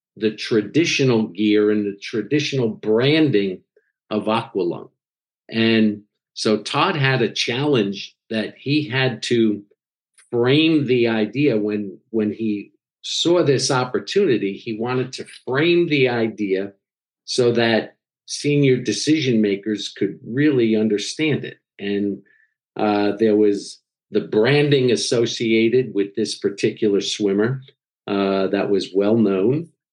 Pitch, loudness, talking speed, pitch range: 115 Hz, -20 LUFS, 120 wpm, 105-135 Hz